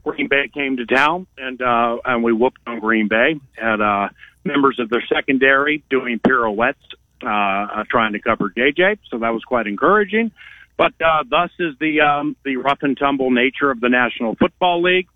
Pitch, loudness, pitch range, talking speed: 130 Hz, -18 LUFS, 115-150 Hz, 185 wpm